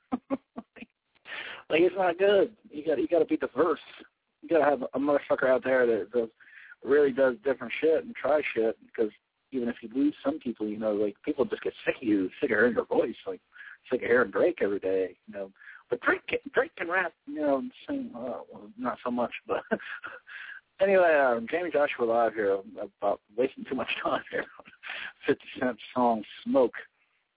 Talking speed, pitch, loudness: 195 wpm, 155 Hz, -28 LUFS